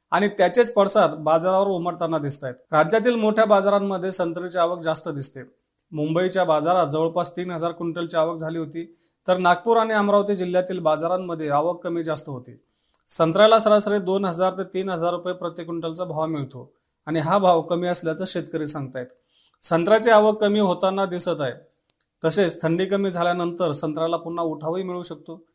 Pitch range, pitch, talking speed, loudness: 160-190 Hz, 175 Hz, 155 wpm, -21 LUFS